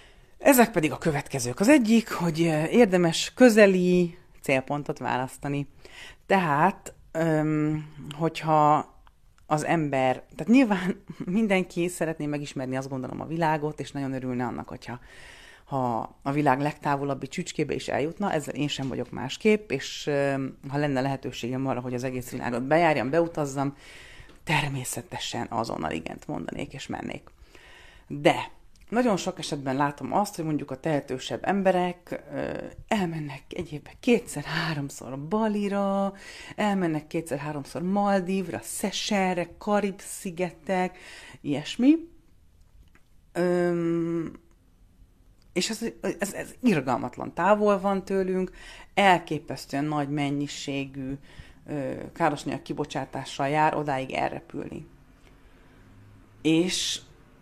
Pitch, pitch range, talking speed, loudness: 155 Hz, 135-185 Hz, 105 wpm, -26 LUFS